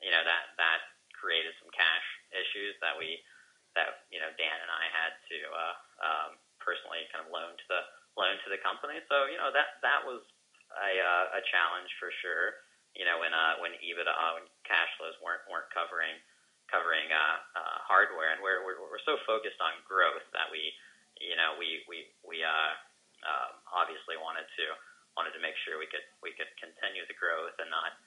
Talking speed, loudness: 195 wpm, -32 LUFS